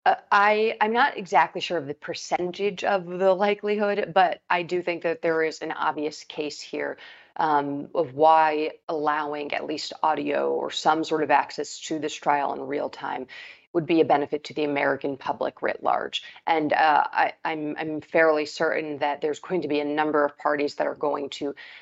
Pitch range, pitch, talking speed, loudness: 150-180 Hz, 155 Hz, 195 wpm, -25 LUFS